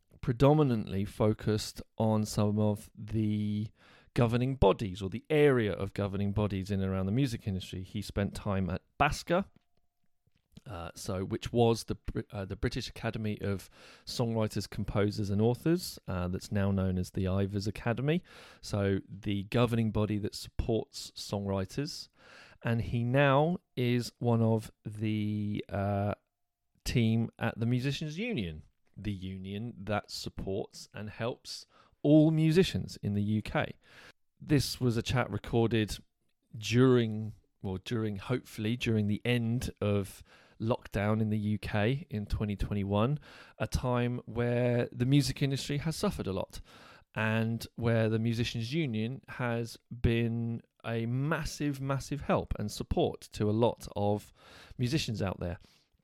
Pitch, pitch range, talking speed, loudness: 110 Hz, 100-120 Hz, 135 wpm, -32 LUFS